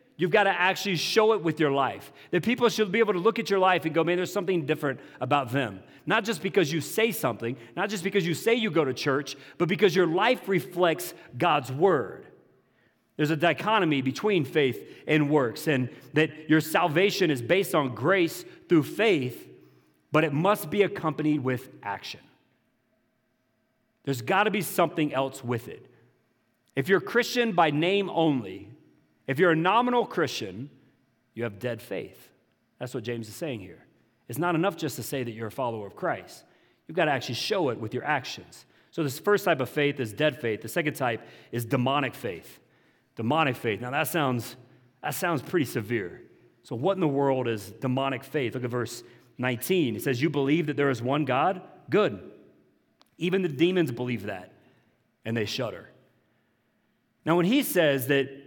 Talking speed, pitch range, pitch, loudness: 190 wpm, 130-180 Hz, 150 Hz, -26 LUFS